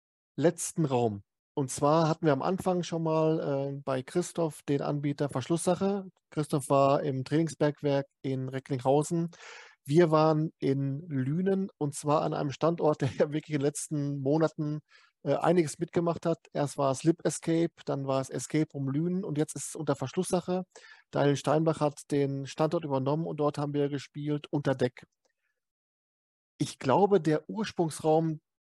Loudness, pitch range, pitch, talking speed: -30 LUFS, 140-165 Hz, 150 Hz, 155 wpm